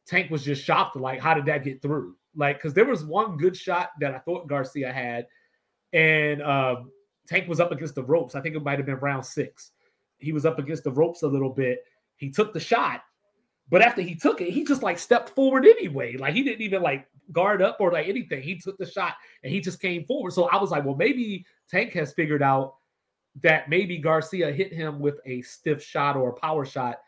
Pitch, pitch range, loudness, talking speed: 160 Hz, 140-185 Hz, -24 LUFS, 230 wpm